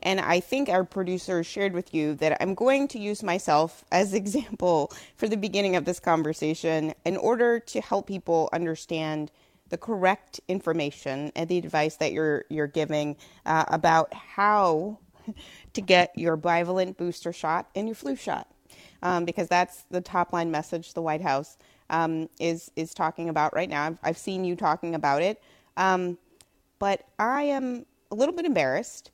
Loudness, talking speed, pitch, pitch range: -27 LUFS, 170 wpm, 175 Hz, 160-200 Hz